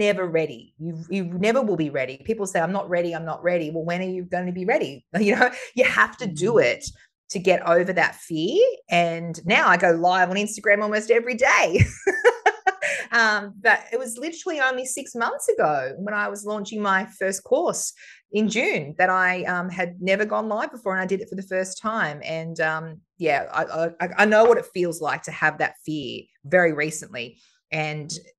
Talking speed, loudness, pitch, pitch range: 205 wpm, -22 LUFS, 190 Hz, 170-220 Hz